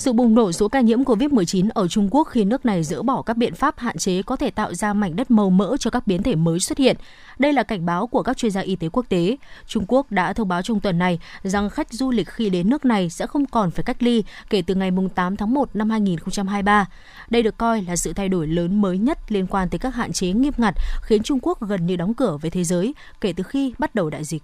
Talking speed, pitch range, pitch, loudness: 275 wpm, 185-245 Hz, 215 Hz, -21 LUFS